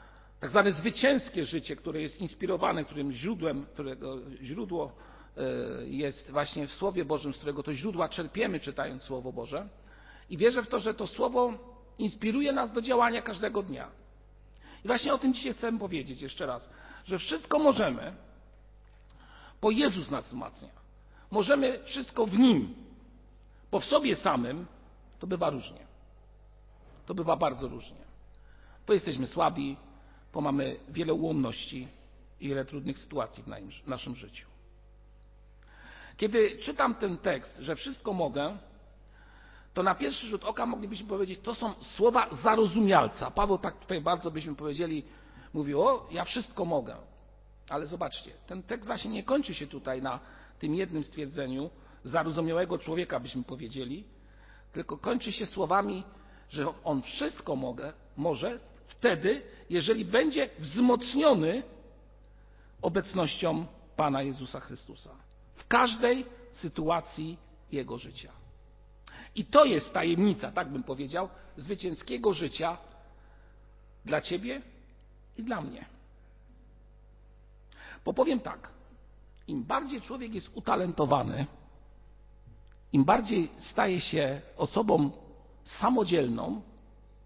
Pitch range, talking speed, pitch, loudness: 135-220 Hz, 120 wpm, 165 Hz, -31 LUFS